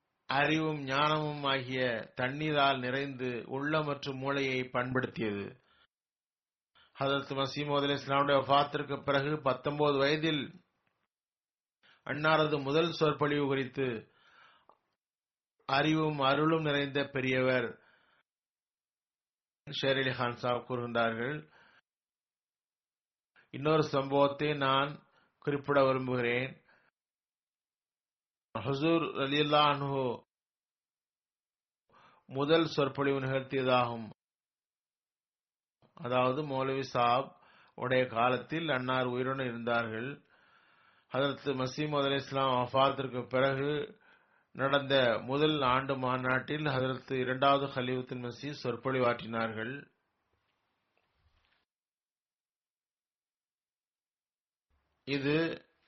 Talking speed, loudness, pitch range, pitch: 55 wpm, -31 LUFS, 130-145 Hz, 135 Hz